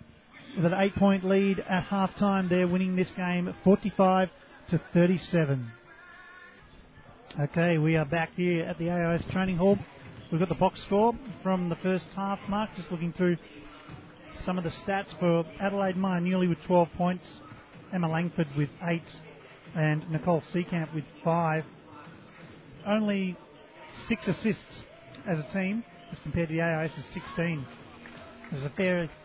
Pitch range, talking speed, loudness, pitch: 160-190 Hz, 150 wpm, -28 LUFS, 175 Hz